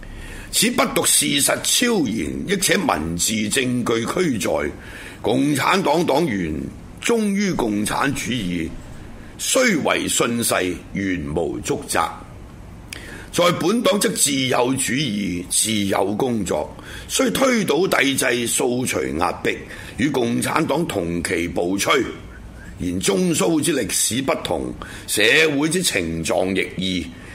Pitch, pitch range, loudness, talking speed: 105 Hz, 90-130 Hz, -19 LUFS, 170 characters per minute